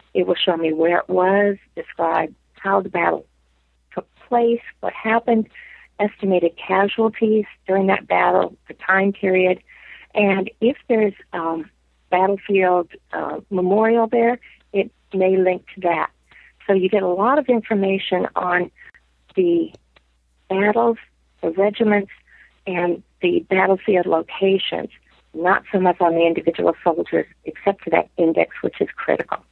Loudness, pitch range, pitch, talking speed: -20 LUFS, 180-220 Hz, 195 Hz, 135 wpm